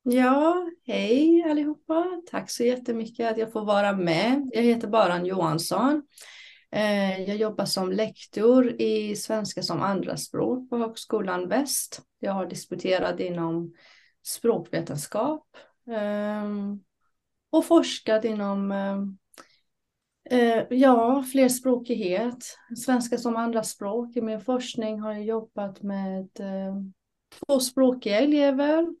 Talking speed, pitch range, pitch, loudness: 100 wpm, 200-255 Hz, 225 Hz, -25 LUFS